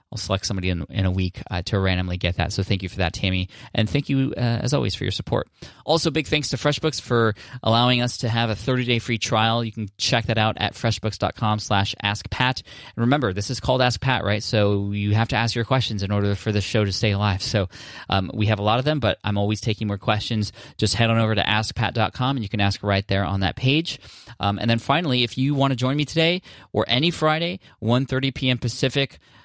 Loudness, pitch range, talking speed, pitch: -22 LUFS, 100-130 Hz, 245 wpm, 115 Hz